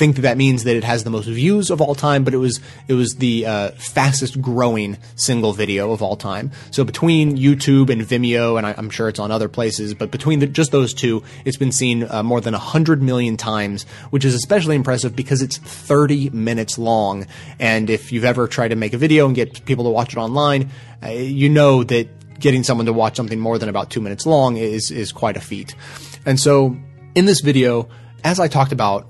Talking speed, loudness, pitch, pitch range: 225 wpm, -17 LUFS, 125 Hz, 115-140 Hz